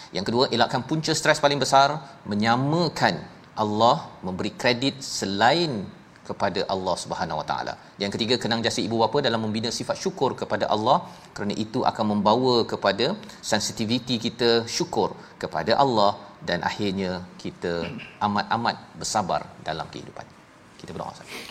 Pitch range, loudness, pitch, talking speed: 110-130 Hz, -24 LUFS, 115 Hz, 135 wpm